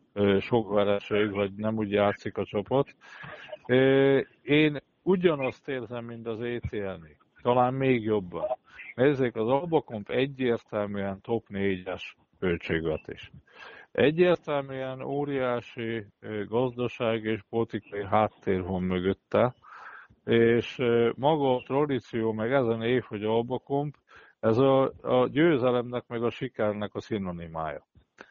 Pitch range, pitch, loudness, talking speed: 105-130 Hz, 115 Hz, -28 LUFS, 105 wpm